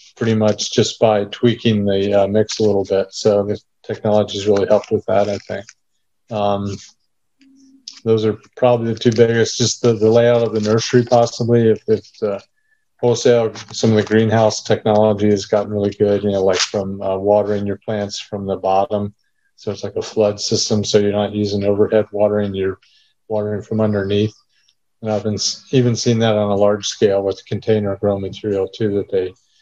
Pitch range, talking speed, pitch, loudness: 100-110 Hz, 190 wpm, 105 Hz, -17 LUFS